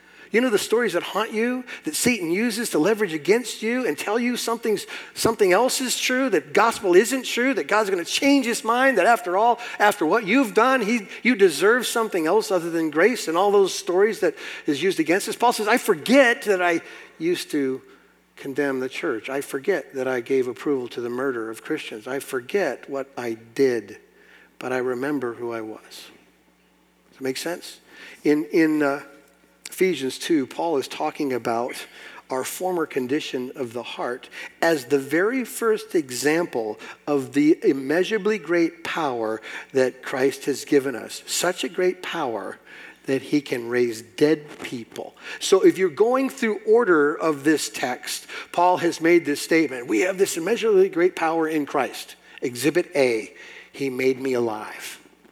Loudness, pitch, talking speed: -22 LUFS, 175 Hz, 175 wpm